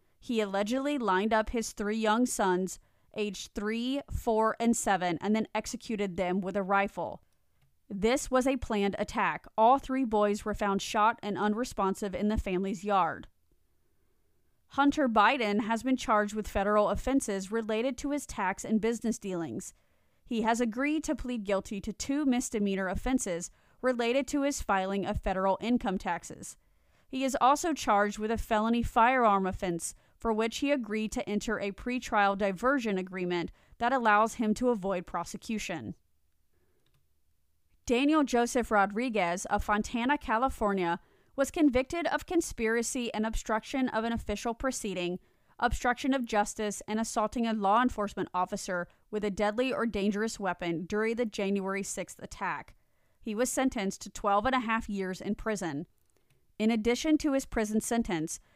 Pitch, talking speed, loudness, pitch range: 215 Hz, 150 wpm, -30 LUFS, 195-245 Hz